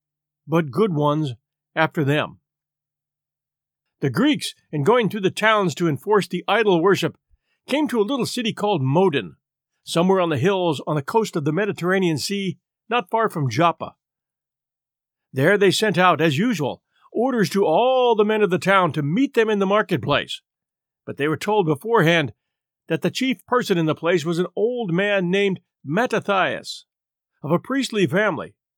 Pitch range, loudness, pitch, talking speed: 150-210 Hz, -20 LUFS, 180 Hz, 170 wpm